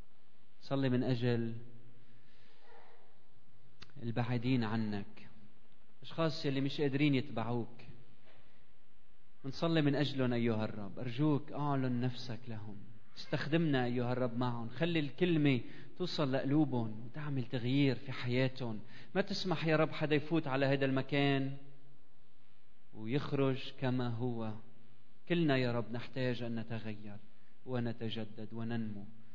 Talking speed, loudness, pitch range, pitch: 105 wpm, -36 LUFS, 115-140 Hz, 125 Hz